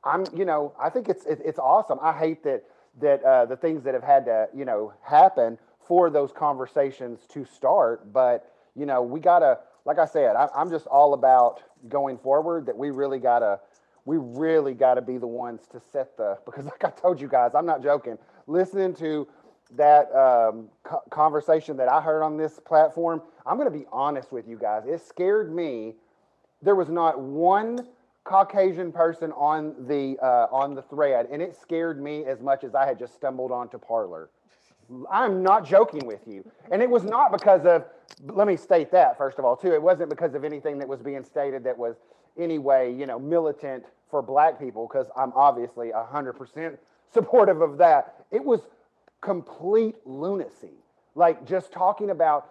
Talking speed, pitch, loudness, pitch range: 190 wpm, 150 Hz, -23 LUFS, 130-175 Hz